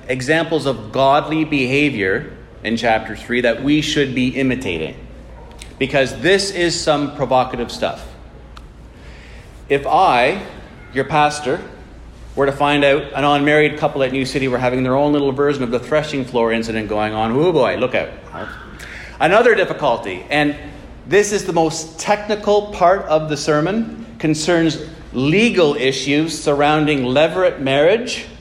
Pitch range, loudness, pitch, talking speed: 125-155 Hz, -17 LUFS, 145 Hz, 140 wpm